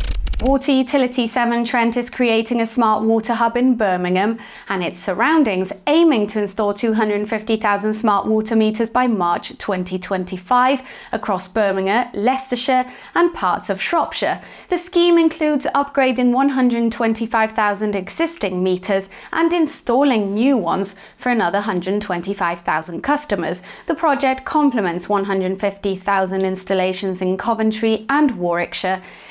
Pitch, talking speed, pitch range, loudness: 220 Hz, 115 wpm, 195-255 Hz, -19 LUFS